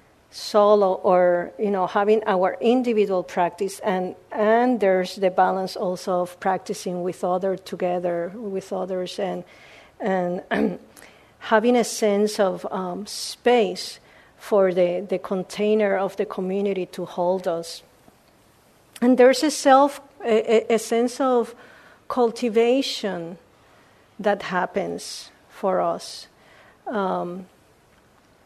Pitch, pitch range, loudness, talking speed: 195 Hz, 180-225 Hz, -22 LUFS, 110 wpm